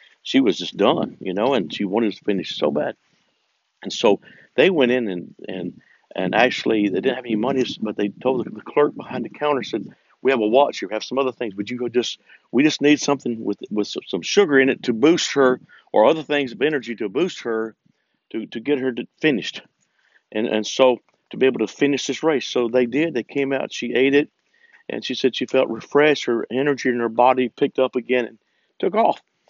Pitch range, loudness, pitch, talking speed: 120-140 Hz, -21 LUFS, 130 Hz, 225 wpm